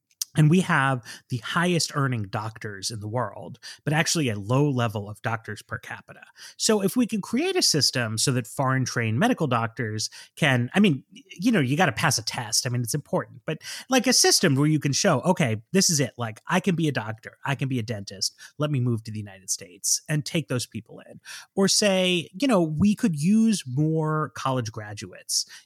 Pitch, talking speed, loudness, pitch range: 140 Hz, 215 wpm, -24 LUFS, 120-175 Hz